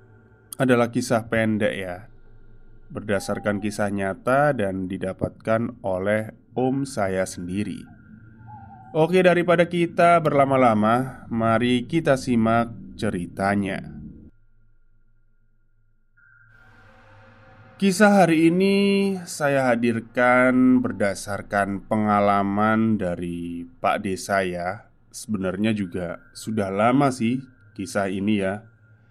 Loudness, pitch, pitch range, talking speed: -22 LUFS, 110 Hz, 100-125 Hz, 80 wpm